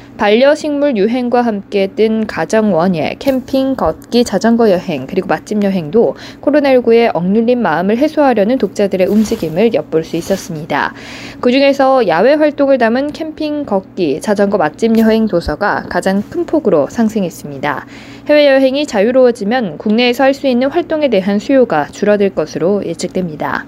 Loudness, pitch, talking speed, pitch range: -13 LUFS, 225 Hz, 345 characters per minute, 195-265 Hz